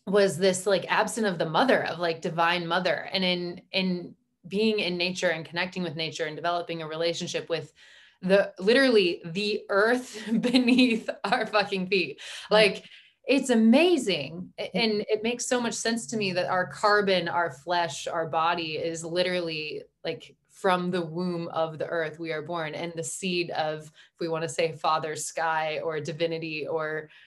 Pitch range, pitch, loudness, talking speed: 165-210 Hz, 180 Hz, -26 LUFS, 170 wpm